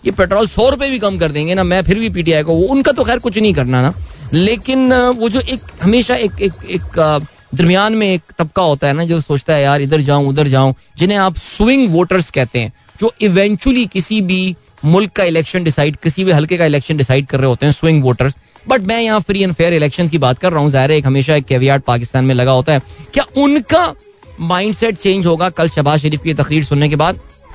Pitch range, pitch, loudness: 145-210 Hz, 170 Hz, -13 LUFS